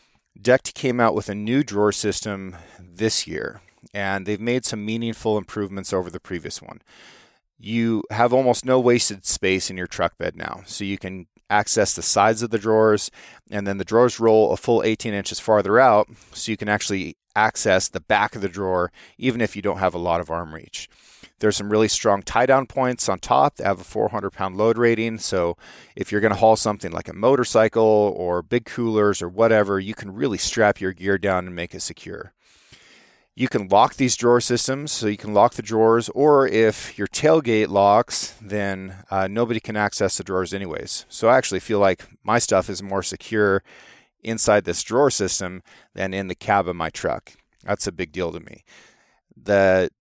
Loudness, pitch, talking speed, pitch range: -21 LUFS, 105 Hz, 195 wpm, 95-115 Hz